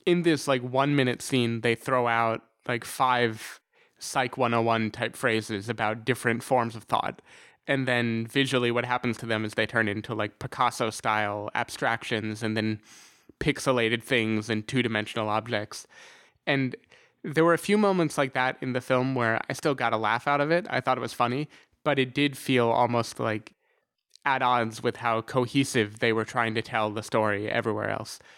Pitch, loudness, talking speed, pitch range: 120 Hz, -27 LUFS, 185 wpm, 110-130 Hz